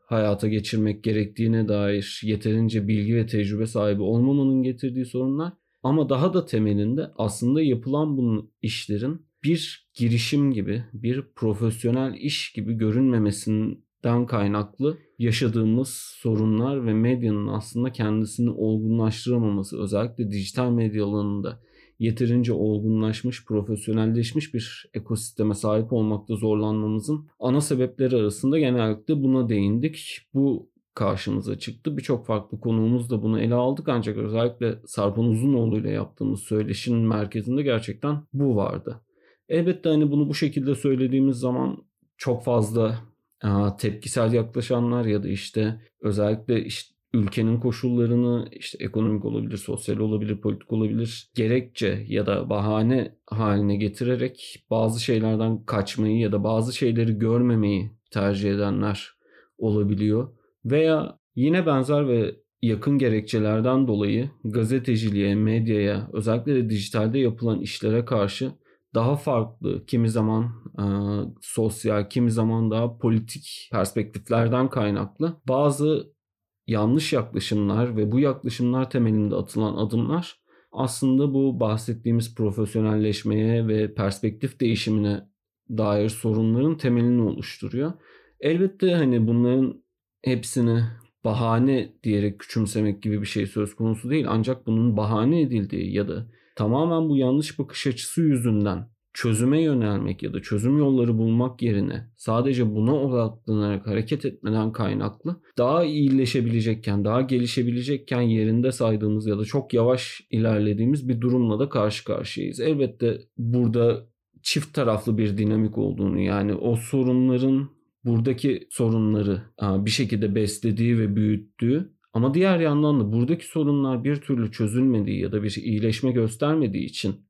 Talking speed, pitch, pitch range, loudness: 120 wpm, 115 Hz, 105-130 Hz, -24 LUFS